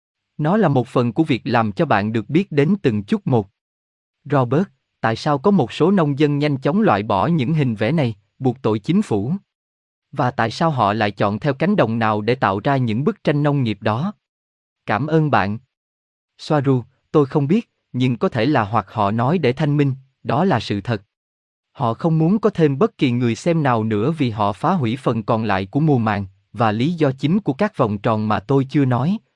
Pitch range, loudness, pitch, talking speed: 110-150 Hz, -19 LUFS, 125 Hz, 220 wpm